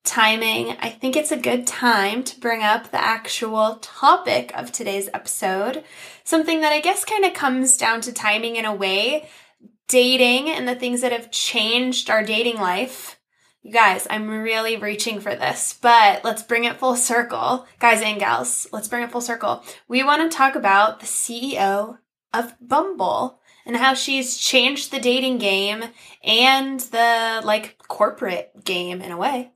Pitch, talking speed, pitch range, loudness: 235 Hz, 170 wpm, 220-260 Hz, -19 LUFS